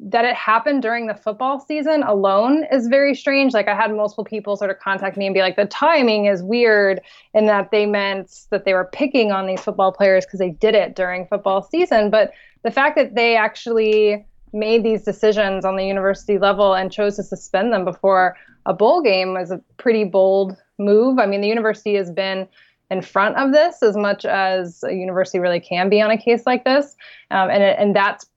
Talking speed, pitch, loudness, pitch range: 215 wpm, 205 Hz, -18 LUFS, 195-230 Hz